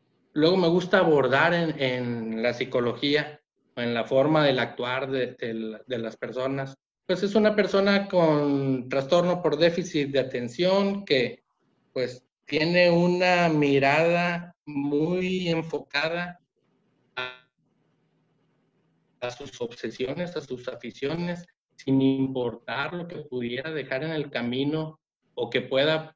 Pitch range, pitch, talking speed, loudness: 125-175 Hz, 145 Hz, 125 wpm, -25 LUFS